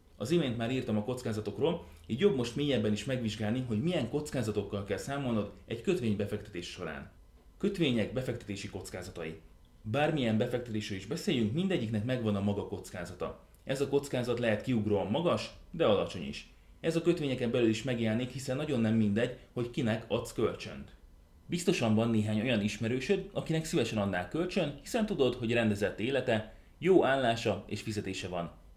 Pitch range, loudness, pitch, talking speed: 105-130 Hz, -32 LUFS, 115 Hz, 155 wpm